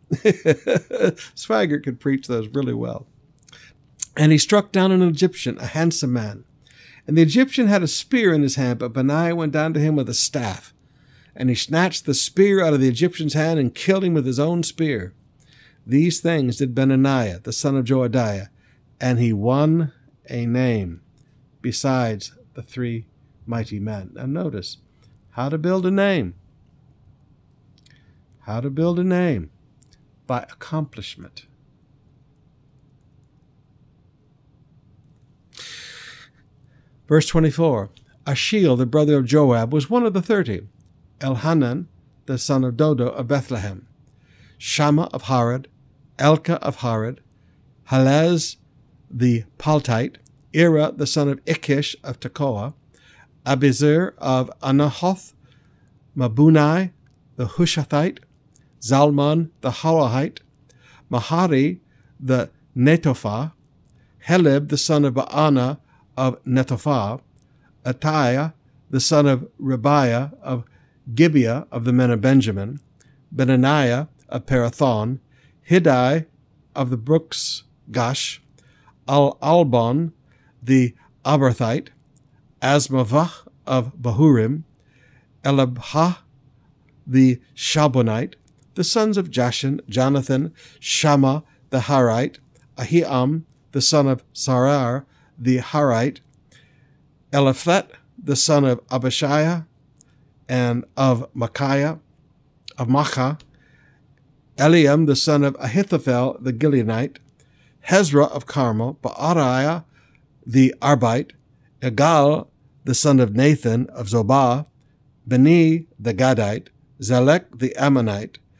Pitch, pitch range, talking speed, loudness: 135 Hz, 125-150 Hz, 110 wpm, -20 LUFS